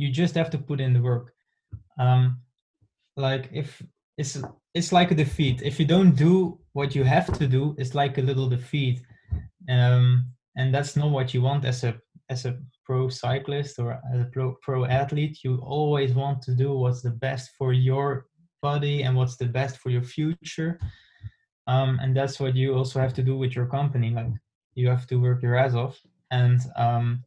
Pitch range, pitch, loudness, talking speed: 125-140 Hz, 130 Hz, -25 LUFS, 195 wpm